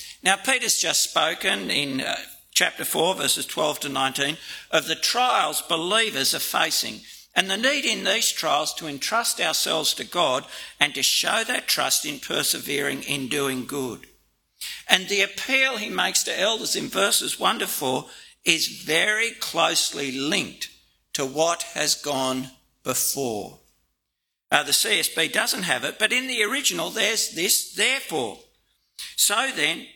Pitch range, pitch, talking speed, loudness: 140-215 Hz, 170 Hz, 150 wpm, -22 LUFS